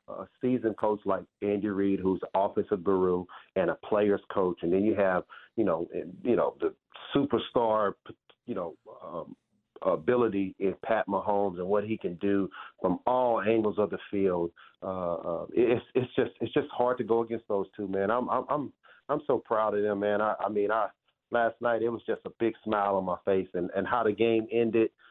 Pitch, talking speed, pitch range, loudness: 105 Hz, 205 wpm, 95-115 Hz, -29 LUFS